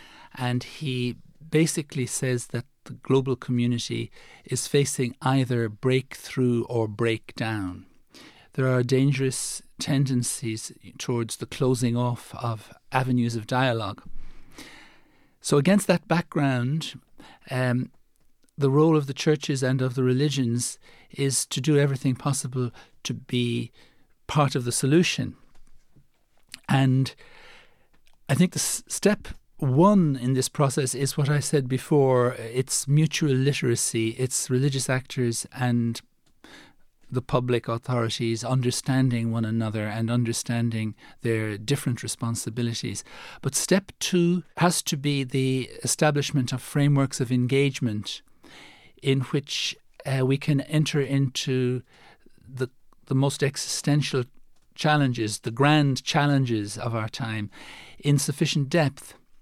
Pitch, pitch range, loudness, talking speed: 130 Hz, 120-145 Hz, -25 LUFS, 120 wpm